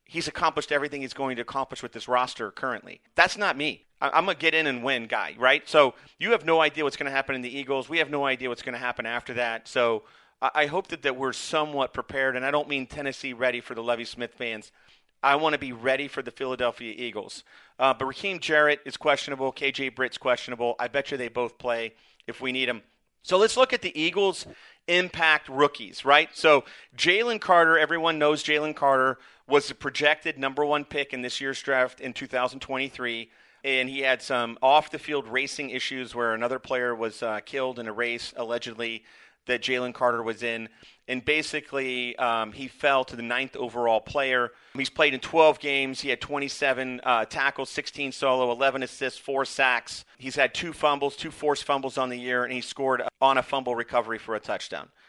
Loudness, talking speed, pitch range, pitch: -26 LUFS, 205 wpm, 125-145 Hz, 135 Hz